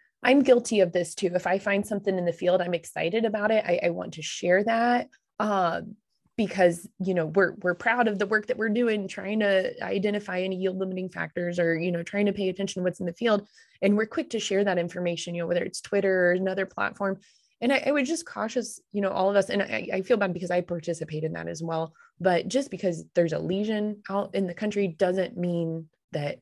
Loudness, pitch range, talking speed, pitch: -27 LUFS, 175-210 Hz, 240 wpm, 190 Hz